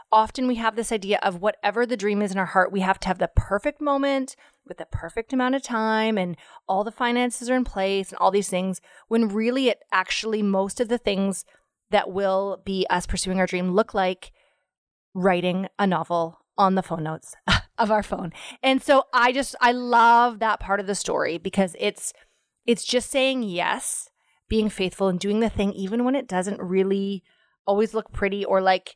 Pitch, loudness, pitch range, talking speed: 205 Hz, -23 LUFS, 190-240 Hz, 200 wpm